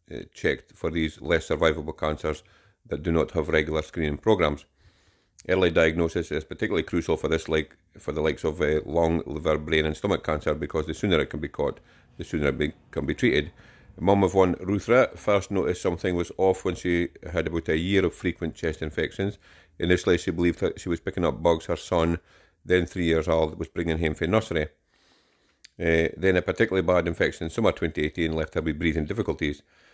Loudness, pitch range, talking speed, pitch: -26 LUFS, 80-90 Hz, 200 wpm, 85 Hz